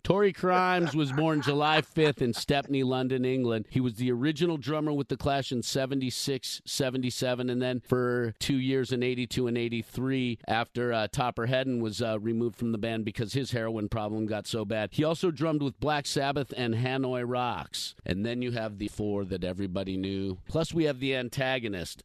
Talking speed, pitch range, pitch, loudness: 195 wpm, 115-140 Hz, 125 Hz, -29 LUFS